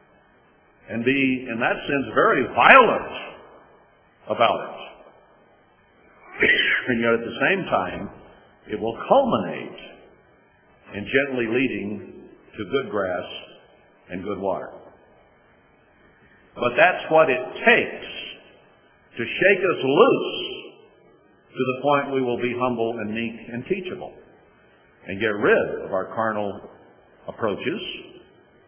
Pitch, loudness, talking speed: 135 Hz, -21 LUFS, 115 wpm